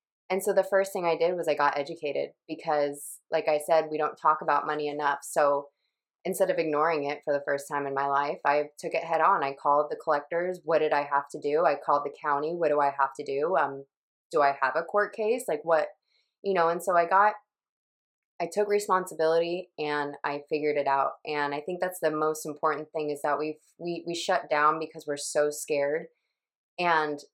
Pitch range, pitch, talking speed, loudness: 145-170 Hz, 155 Hz, 220 wpm, -28 LUFS